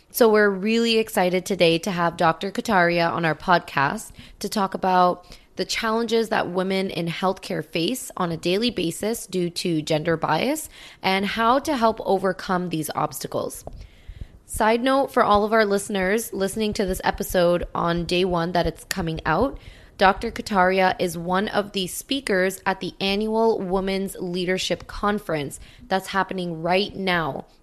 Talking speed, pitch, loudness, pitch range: 155 wpm, 185 Hz, -23 LUFS, 170-210 Hz